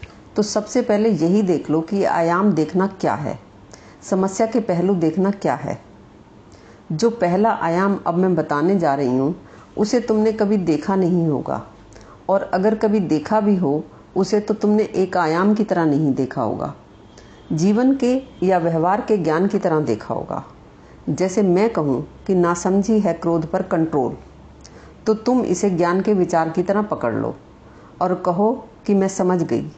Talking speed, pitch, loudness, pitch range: 165 wpm, 185 Hz, -19 LUFS, 160-210 Hz